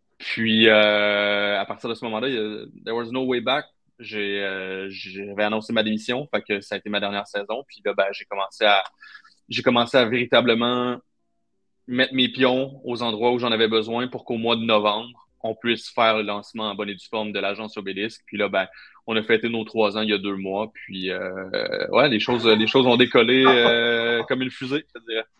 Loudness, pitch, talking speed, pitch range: -22 LUFS, 110 Hz, 215 wpm, 105-120 Hz